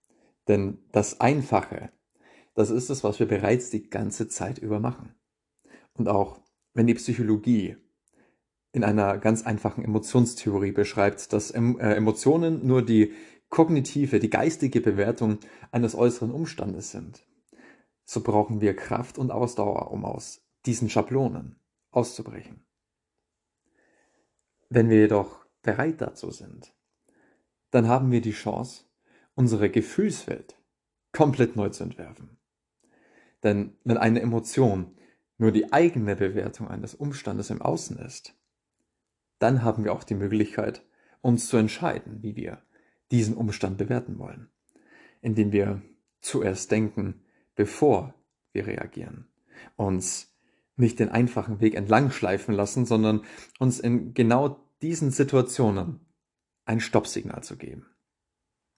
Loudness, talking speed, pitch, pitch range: -25 LUFS, 120 wpm, 110 Hz, 105-120 Hz